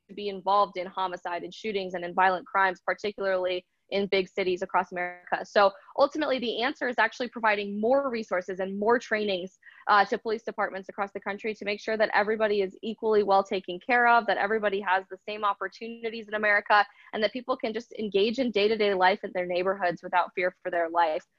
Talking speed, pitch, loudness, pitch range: 200 wpm, 200 Hz, -27 LUFS, 185-220 Hz